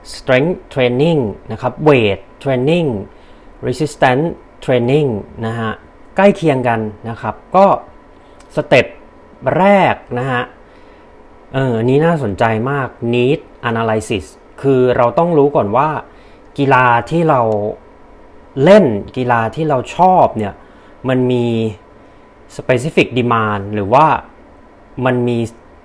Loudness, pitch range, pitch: -14 LUFS, 110-140 Hz, 125 Hz